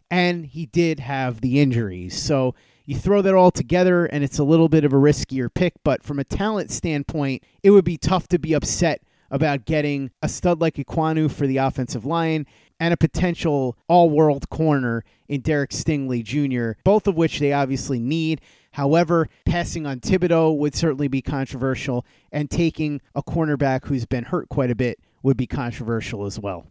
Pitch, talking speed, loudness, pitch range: 145 Hz, 185 wpm, -21 LUFS, 130-165 Hz